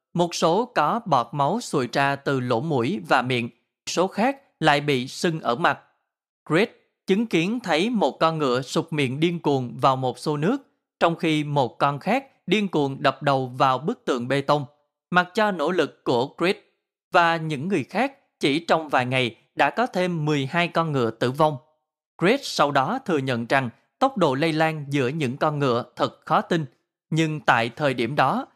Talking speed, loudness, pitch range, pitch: 195 wpm, -23 LUFS, 135-175 Hz, 155 Hz